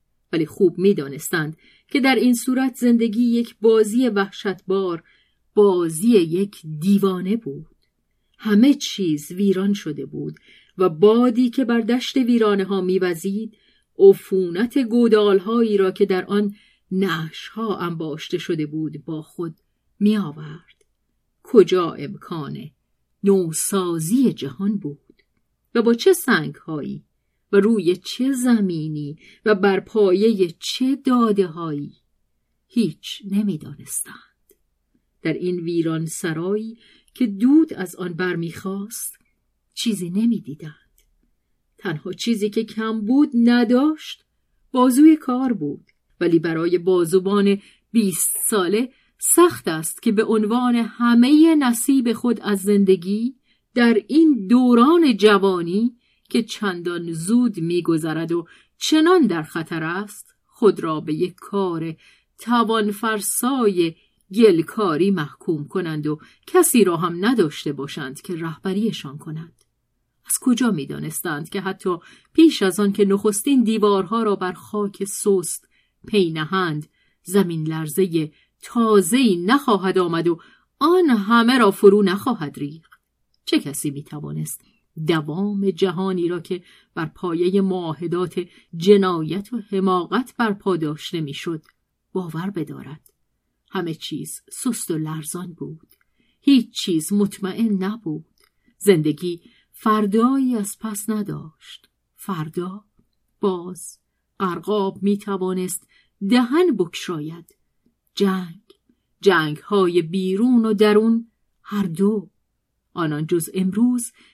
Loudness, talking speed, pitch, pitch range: -20 LUFS, 110 wpm, 195 Hz, 170-230 Hz